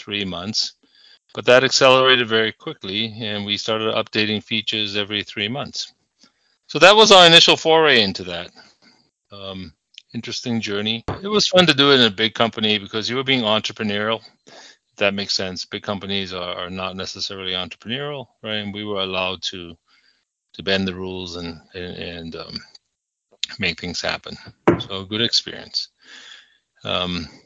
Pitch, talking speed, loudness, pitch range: 105 Hz, 160 wpm, -18 LUFS, 95-115 Hz